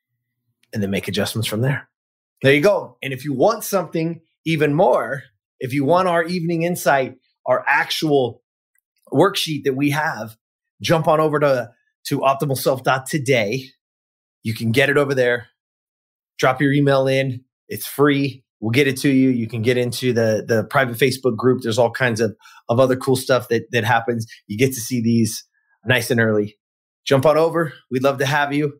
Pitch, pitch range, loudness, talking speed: 135 Hz, 120-150 Hz, -19 LUFS, 180 wpm